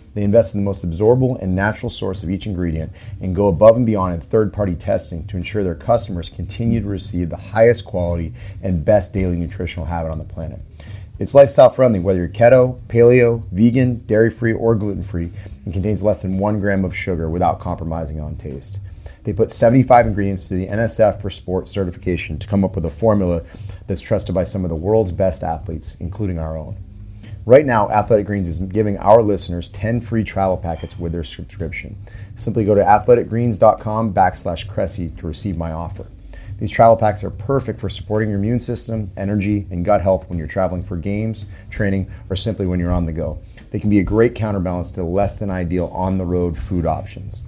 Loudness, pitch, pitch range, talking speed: -18 LUFS, 100 Hz, 90-110 Hz, 200 wpm